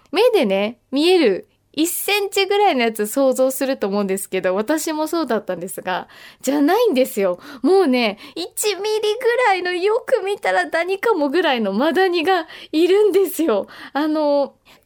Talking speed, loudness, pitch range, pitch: 320 characters per minute, -19 LUFS, 260-395 Hz, 320 Hz